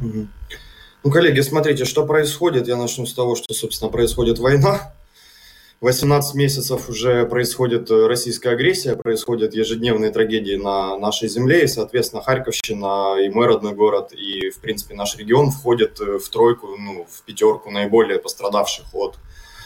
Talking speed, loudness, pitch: 140 wpm, -19 LUFS, 125 Hz